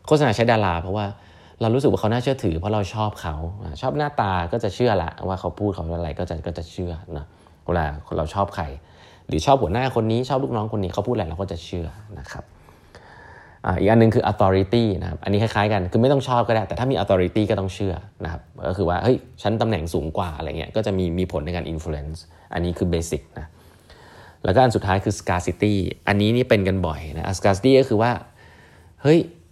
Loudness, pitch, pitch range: -22 LUFS, 95 Hz, 85-110 Hz